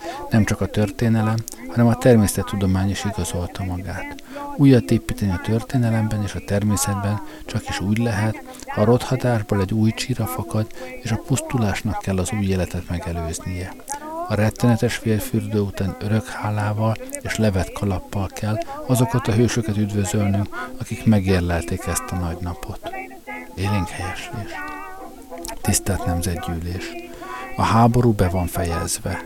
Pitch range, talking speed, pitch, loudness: 95-115 Hz, 135 wpm, 105 Hz, -22 LUFS